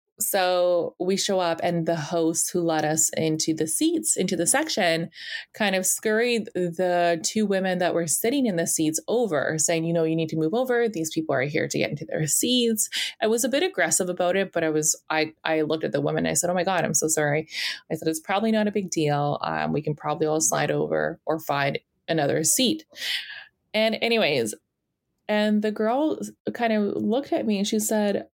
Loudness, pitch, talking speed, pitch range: -24 LUFS, 175 Hz, 215 wpm, 160-215 Hz